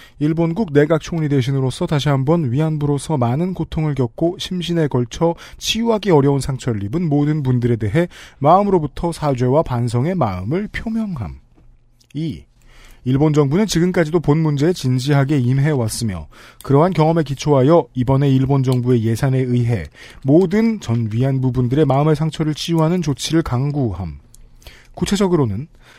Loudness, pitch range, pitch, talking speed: -17 LUFS, 125-165 Hz, 145 Hz, 340 characters per minute